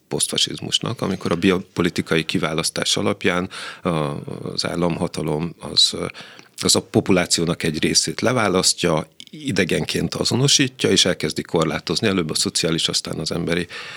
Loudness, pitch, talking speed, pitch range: -20 LUFS, 90 Hz, 110 wpm, 85-95 Hz